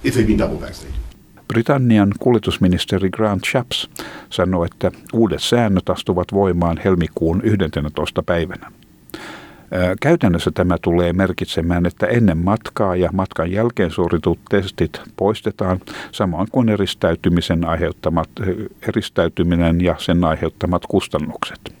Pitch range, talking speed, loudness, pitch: 85-105 Hz, 95 wpm, -18 LUFS, 90 Hz